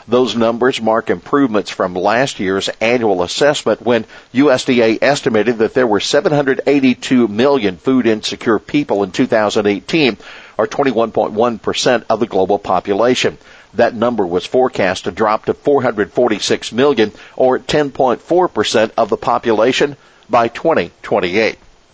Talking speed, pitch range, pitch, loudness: 120 wpm, 110-135 Hz, 125 Hz, -15 LUFS